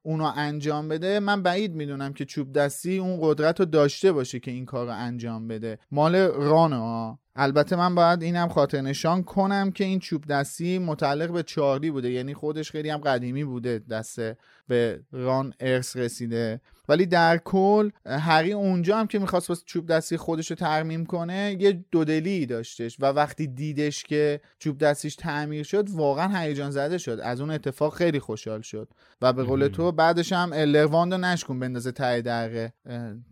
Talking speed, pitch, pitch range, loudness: 175 wpm, 150 Hz, 130-170 Hz, -25 LUFS